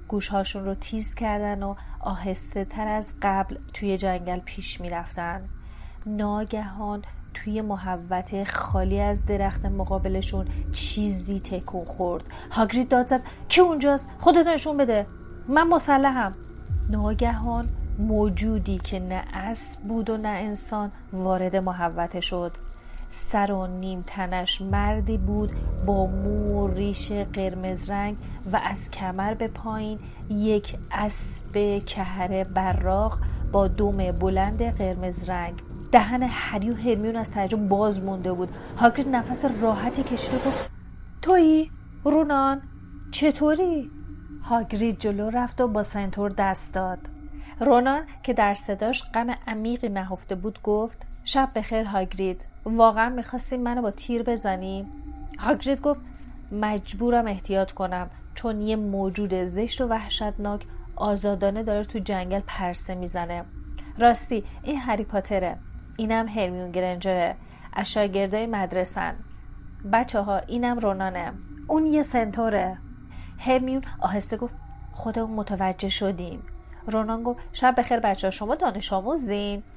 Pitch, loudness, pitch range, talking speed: 205 Hz, -24 LUFS, 185-230 Hz, 125 wpm